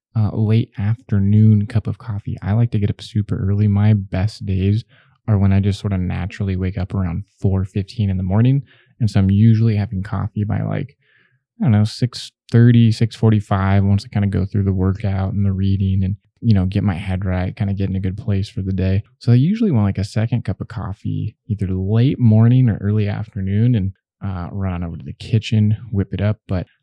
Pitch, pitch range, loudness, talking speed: 105 Hz, 95-115 Hz, -18 LUFS, 225 wpm